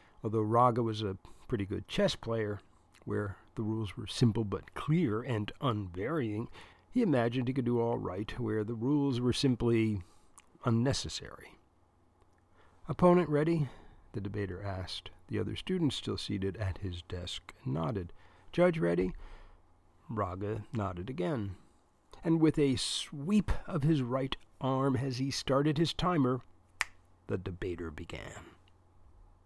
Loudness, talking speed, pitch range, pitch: -33 LUFS, 130 wpm, 95-130 Hz, 110 Hz